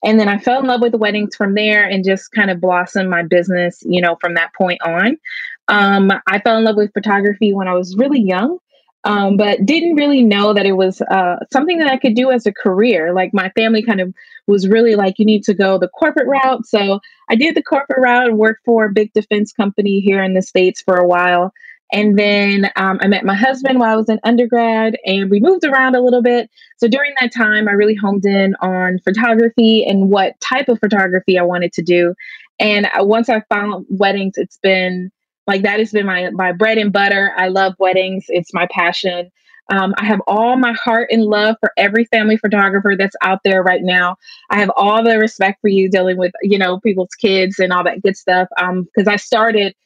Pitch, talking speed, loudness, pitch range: 205 Hz, 225 wpm, -14 LUFS, 190-230 Hz